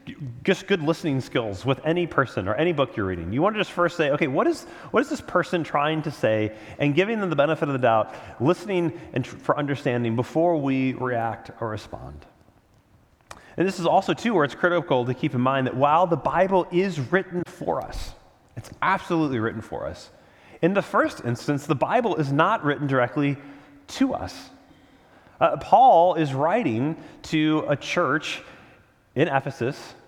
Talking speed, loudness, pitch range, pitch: 185 wpm, -23 LUFS, 125-175 Hz, 145 Hz